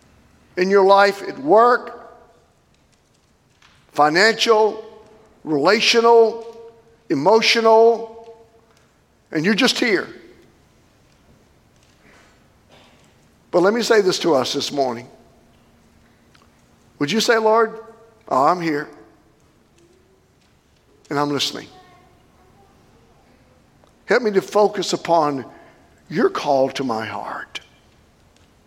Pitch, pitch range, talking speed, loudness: 220 Hz, 165-230 Hz, 85 wpm, -17 LUFS